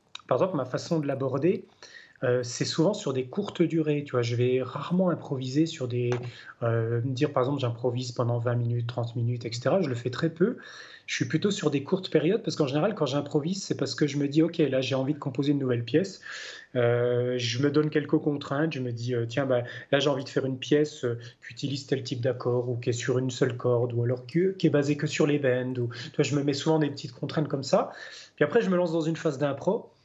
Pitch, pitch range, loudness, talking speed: 140 Hz, 125-155 Hz, -28 LUFS, 255 wpm